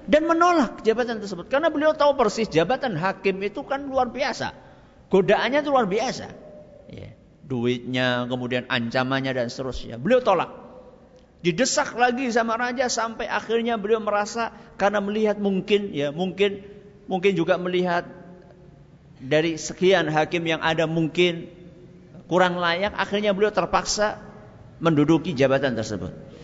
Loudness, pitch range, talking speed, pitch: -23 LUFS, 160-230 Hz, 125 wpm, 190 Hz